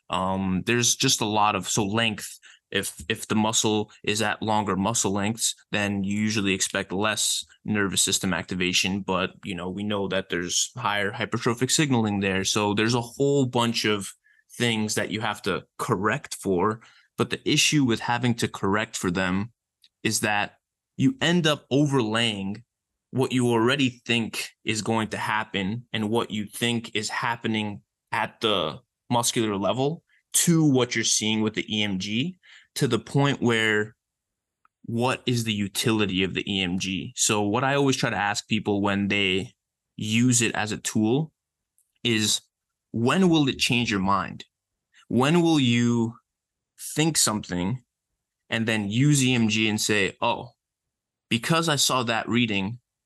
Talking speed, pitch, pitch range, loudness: 155 wpm, 110 Hz, 100-120 Hz, -24 LUFS